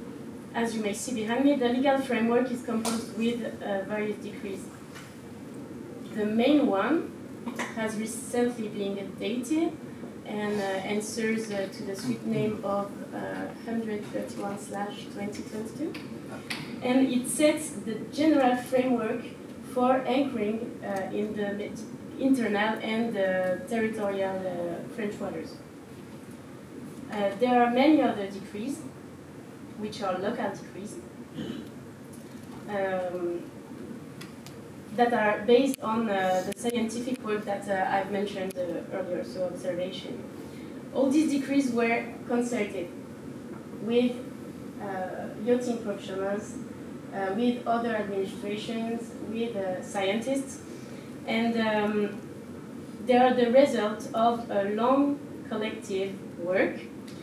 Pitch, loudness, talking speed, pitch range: 230 Hz, -29 LUFS, 110 wpm, 205-250 Hz